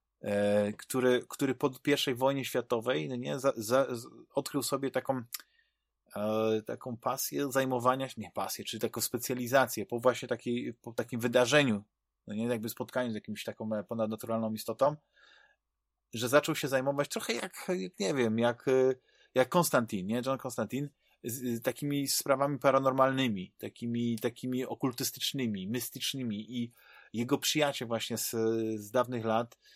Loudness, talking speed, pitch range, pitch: -32 LUFS, 145 wpm, 115-135 Hz, 125 Hz